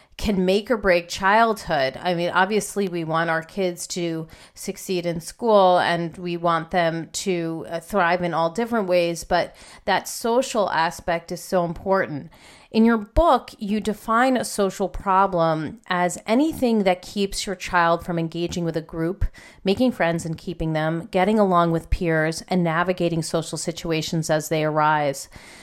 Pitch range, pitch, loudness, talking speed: 165-200 Hz, 175 Hz, -22 LUFS, 160 wpm